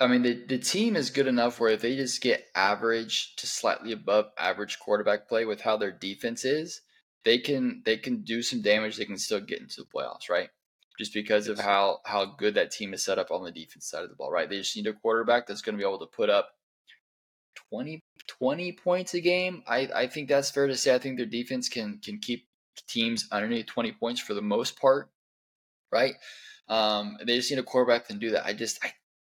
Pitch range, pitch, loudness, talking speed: 110-140 Hz, 120 Hz, -28 LUFS, 230 wpm